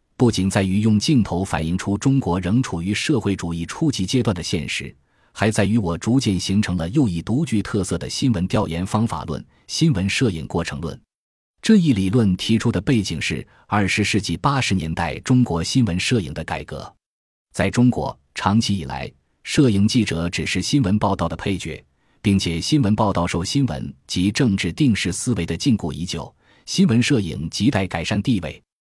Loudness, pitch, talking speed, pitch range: -20 LUFS, 100 Hz, 280 characters per minute, 90-120 Hz